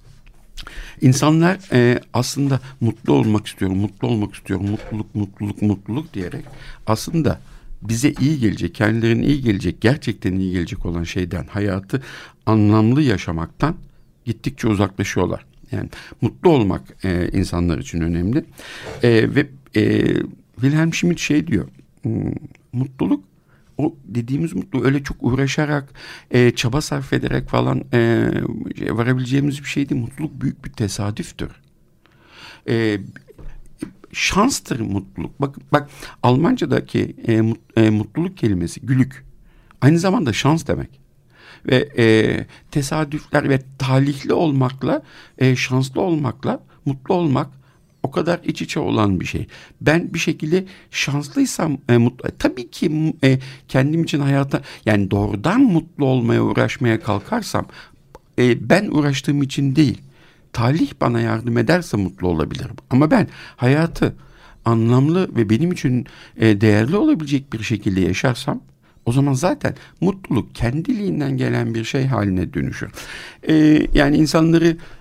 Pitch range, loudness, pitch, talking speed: 110-150 Hz, -19 LUFS, 130 Hz, 120 wpm